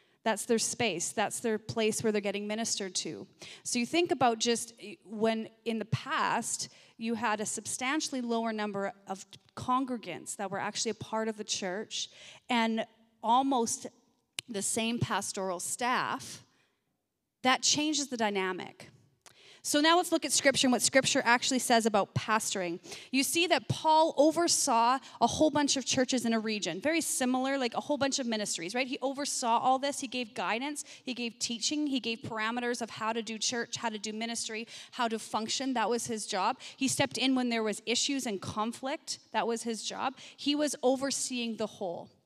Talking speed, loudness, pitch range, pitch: 180 wpm, -30 LUFS, 220-265 Hz, 235 Hz